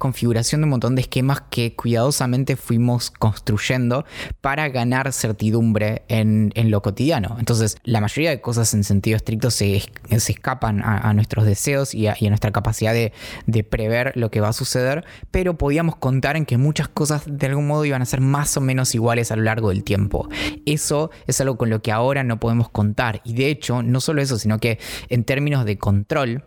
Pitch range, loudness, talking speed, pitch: 110-135 Hz, -20 LUFS, 205 wpm, 120 Hz